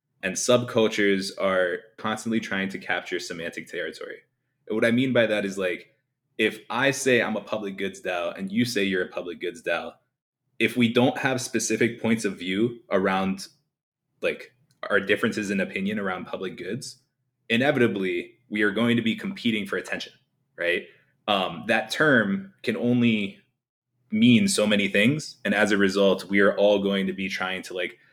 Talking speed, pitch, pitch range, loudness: 175 wpm, 115 Hz, 100-130 Hz, -25 LUFS